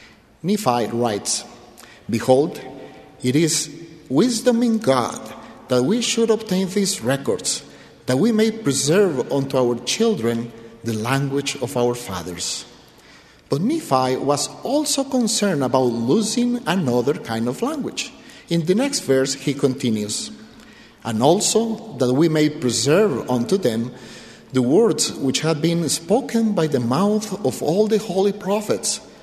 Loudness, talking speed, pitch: -20 LUFS, 135 wpm, 150 Hz